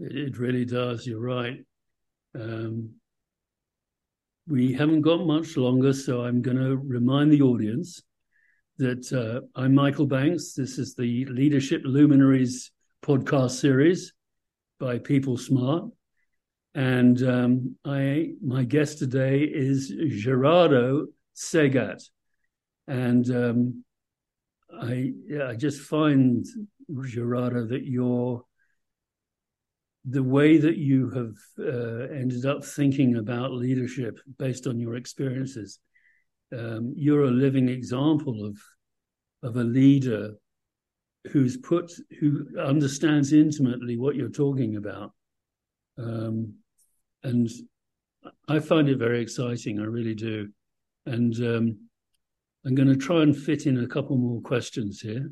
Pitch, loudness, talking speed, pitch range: 130 Hz, -25 LUFS, 120 wpm, 120-140 Hz